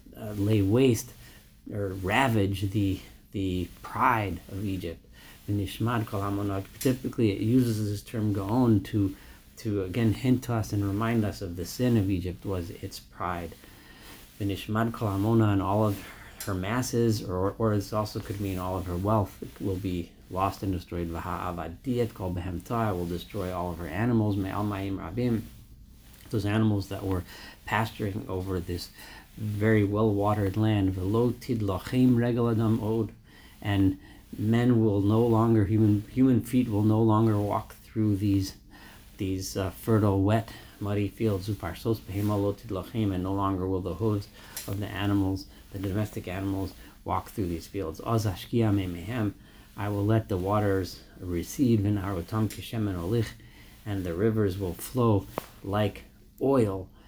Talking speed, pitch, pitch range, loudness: 135 wpm, 100 Hz, 95-110 Hz, -28 LUFS